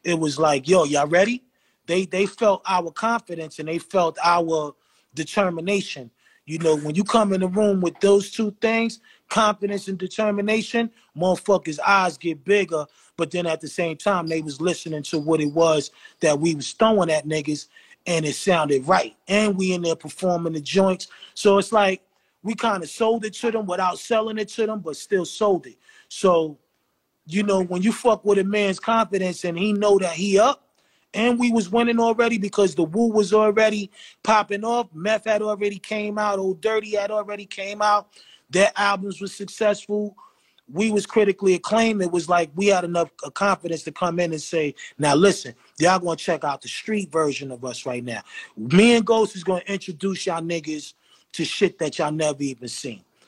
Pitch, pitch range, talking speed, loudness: 190 Hz, 165-210 Hz, 195 wpm, -22 LUFS